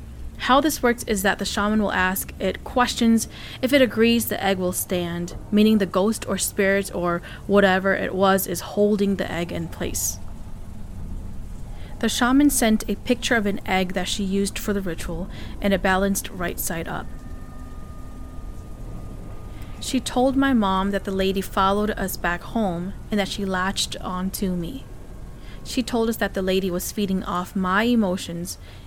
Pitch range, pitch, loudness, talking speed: 175-210 Hz, 195 Hz, -22 LUFS, 170 wpm